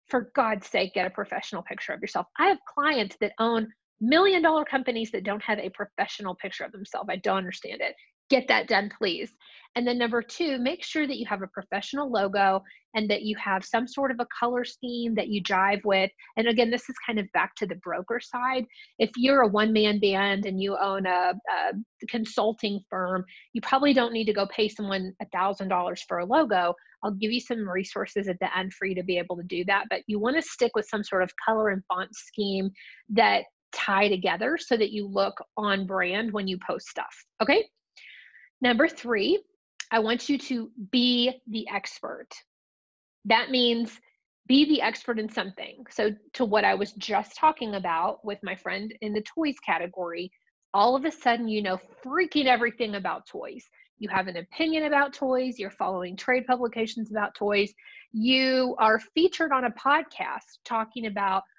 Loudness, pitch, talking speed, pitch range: -27 LUFS, 220 Hz, 195 wpm, 195-255 Hz